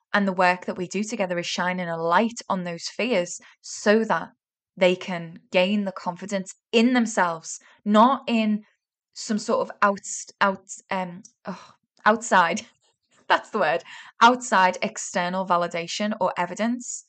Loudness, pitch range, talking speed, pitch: -23 LUFS, 180-220 Hz, 145 wpm, 195 Hz